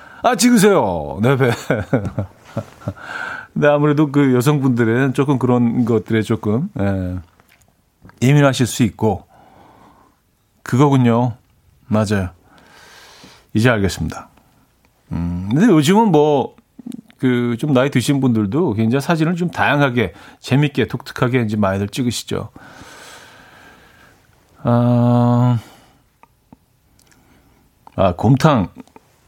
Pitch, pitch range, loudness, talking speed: 125 Hz, 110-145 Hz, -17 LUFS, 195 characters per minute